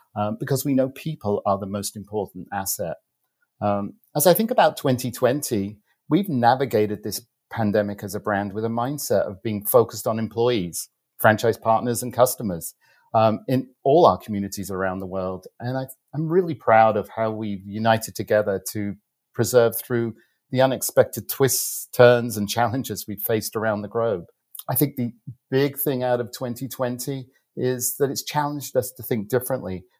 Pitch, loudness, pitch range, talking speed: 115 Hz, -23 LUFS, 105-130 Hz, 165 wpm